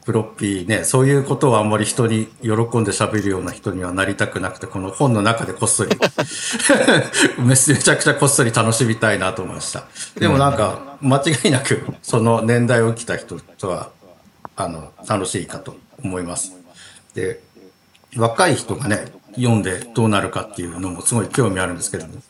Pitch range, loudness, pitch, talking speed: 100-125 Hz, -18 LUFS, 115 Hz, 355 characters per minute